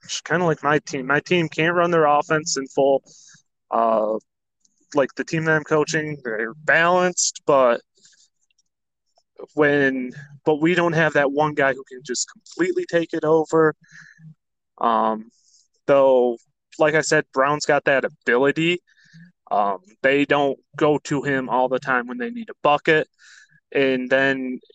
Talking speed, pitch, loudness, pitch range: 155 wpm, 150 Hz, -20 LUFS, 135-160 Hz